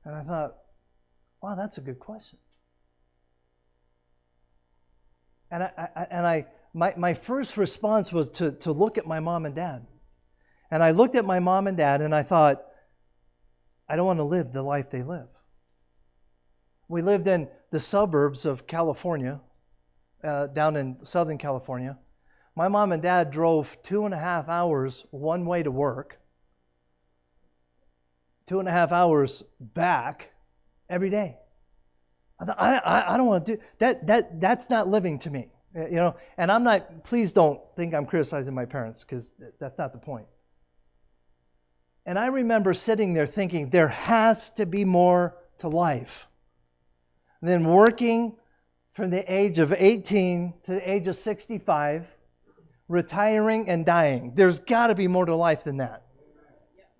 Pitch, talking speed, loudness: 155 Hz, 155 wpm, -25 LUFS